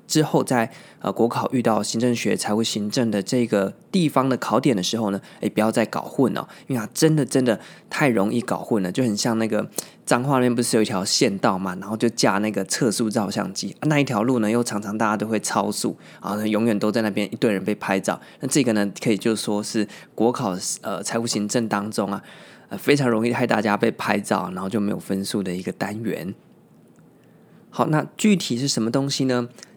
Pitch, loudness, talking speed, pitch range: 110 Hz, -22 LUFS, 320 characters per minute, 105-125 Hz